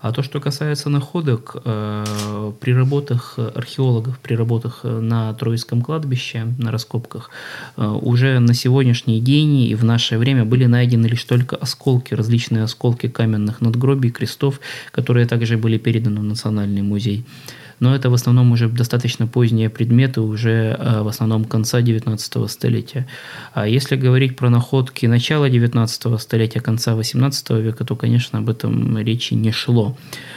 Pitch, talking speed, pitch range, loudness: 120 Hz, 145 wpm, 115-130 Hz, -18 LUFS